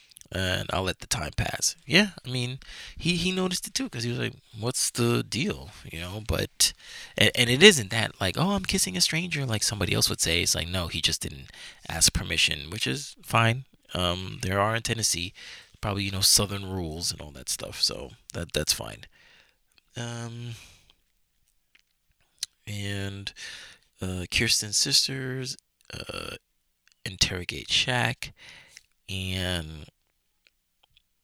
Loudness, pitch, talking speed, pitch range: -25 LUFS, 100 Hz, 150 wpm, 85-125 Hz